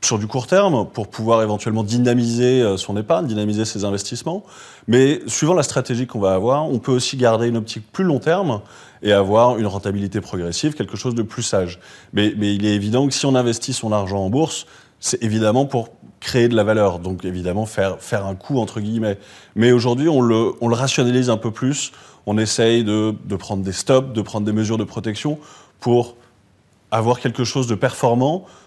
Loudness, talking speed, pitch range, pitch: -19 LUFS, 200 wpm, 105-130 Hz, 115 Hz